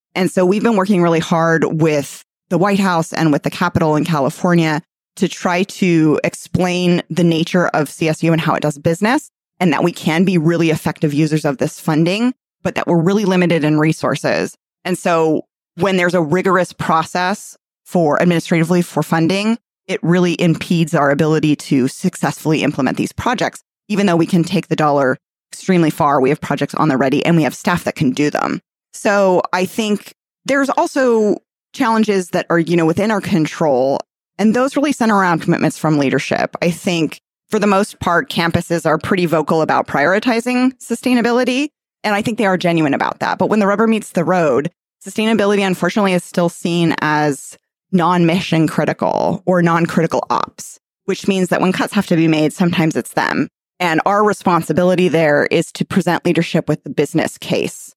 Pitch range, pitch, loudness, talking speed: 160-195 Hz, 175 Hz, -16 LUFS, 185 wpm